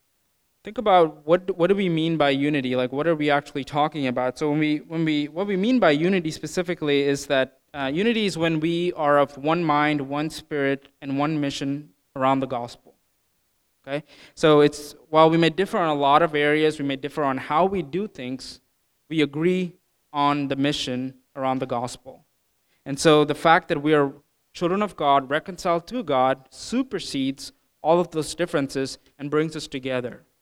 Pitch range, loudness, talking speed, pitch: 140-165 Hz, -23 LUFS, 190 wpm, 150 Hz